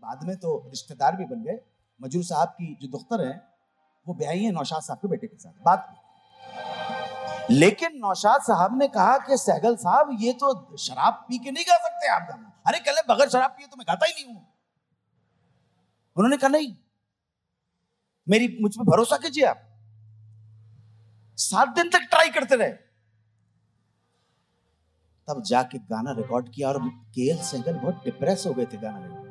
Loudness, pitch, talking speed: -24 LUFS, 180 Hz, 170 wpm